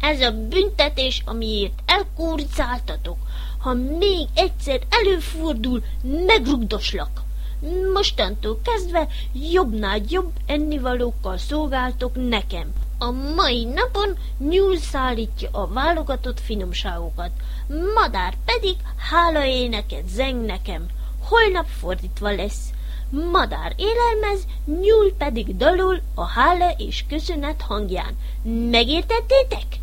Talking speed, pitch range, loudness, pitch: 90 wpm, 240-370 Hz, -22 LUFS, 295 Hz